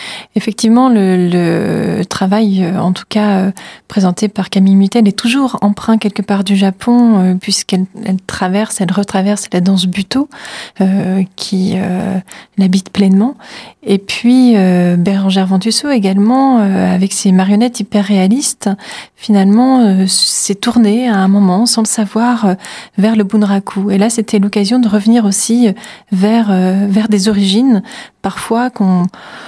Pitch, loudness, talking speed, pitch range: 205 Hz, -12 LUFS, 140 wpm, 190-225 Hz